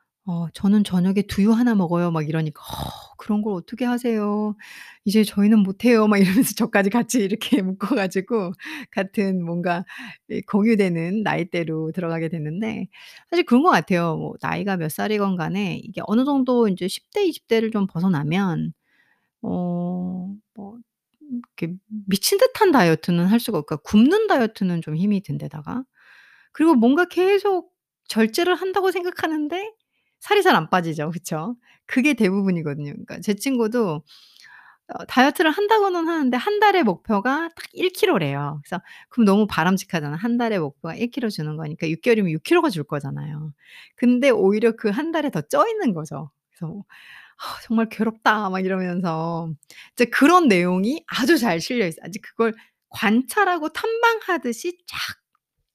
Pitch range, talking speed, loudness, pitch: 175-255 Hz, 325 characters per minute, -21 LUFS, 210 Hz